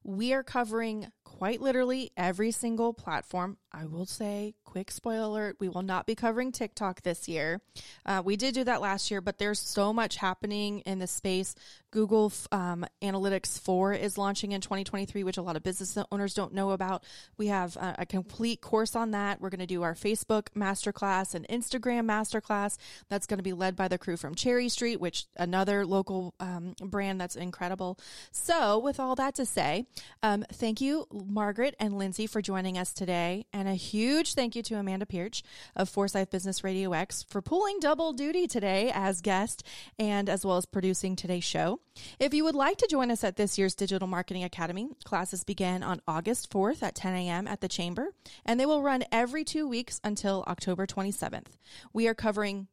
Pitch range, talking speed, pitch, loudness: 185-225 Hz, 195 wpm, 200 Hz, -31 LUFS